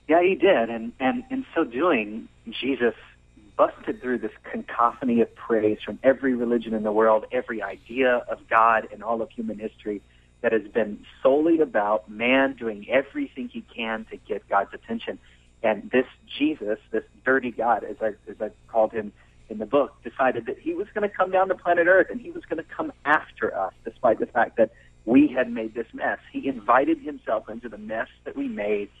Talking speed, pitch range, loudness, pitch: 200 wpm, 110-150 Hz, -24 LUFS, 120 Hz